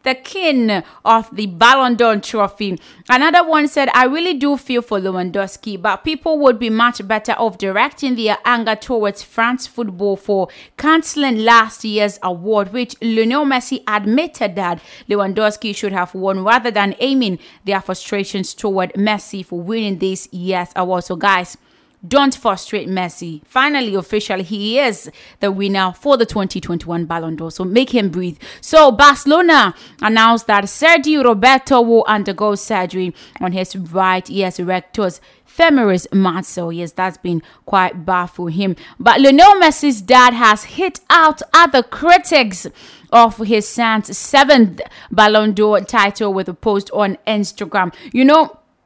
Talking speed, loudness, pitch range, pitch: 150 wpm, -14 LUFS, 190-255 Hz, 215 Hz